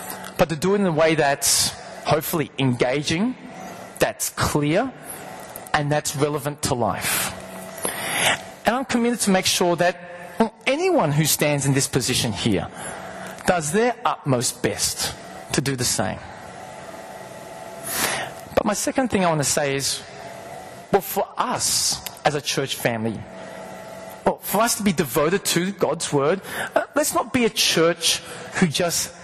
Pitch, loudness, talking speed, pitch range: 165 Hz, -21 LUFS, 145 wpm, 140-200 Hz